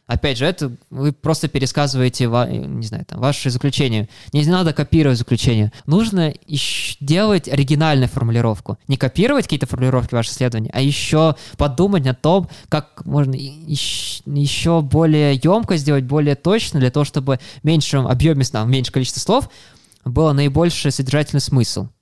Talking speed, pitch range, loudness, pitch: 150 wpm, 130-155 Hz, -18 LUFS, 140 Hz